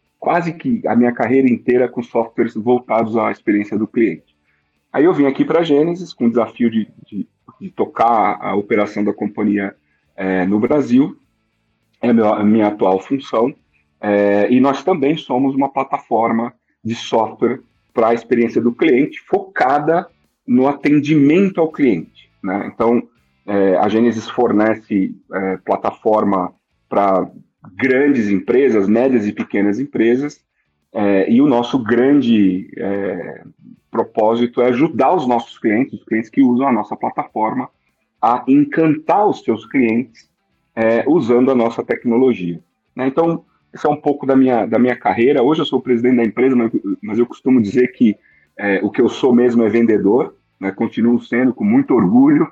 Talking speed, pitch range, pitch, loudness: 160 wpm, 105-135 Hz, 120 Hz, -16 LUFS